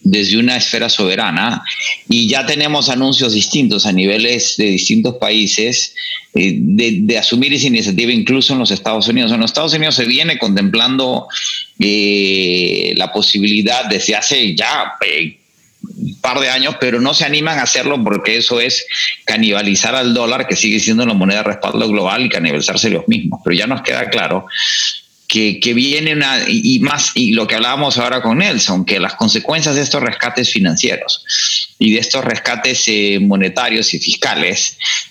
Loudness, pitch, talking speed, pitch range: -13 LUFS, 125 Hz, 170 wpm, 110-160 Hz